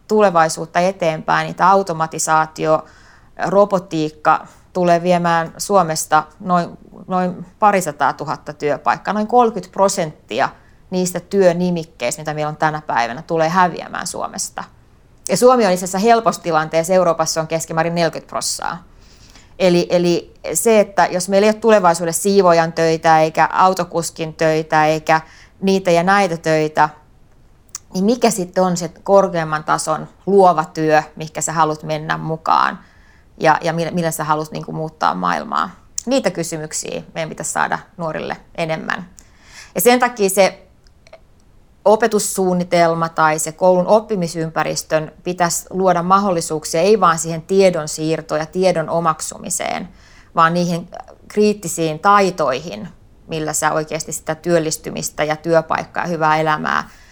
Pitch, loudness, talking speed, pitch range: 165 Hz, -17 LUFS, 125 wpm, 155-190 Hz